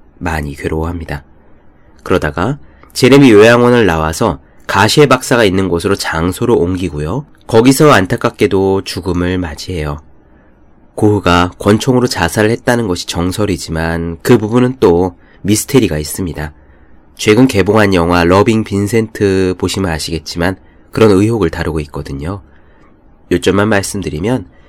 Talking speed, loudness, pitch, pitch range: 315 characters per minute, -12 LUFS, 95 Hz, 80-110 Hz